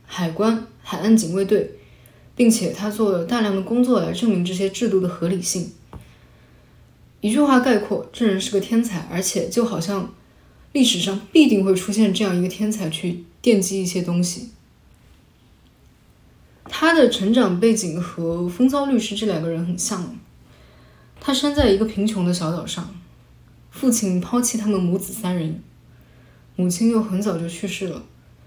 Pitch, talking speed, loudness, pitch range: 200 Hz, 235 characters per minute, -20 LUFS, 180-230 Hz